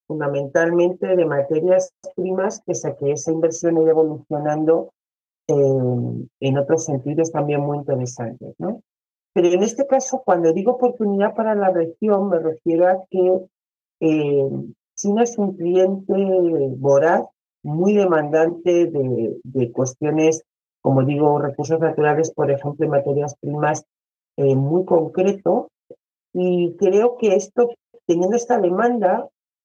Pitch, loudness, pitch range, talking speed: 165 Hz, -19 LUFS, 145-185 Hz, 125 wpm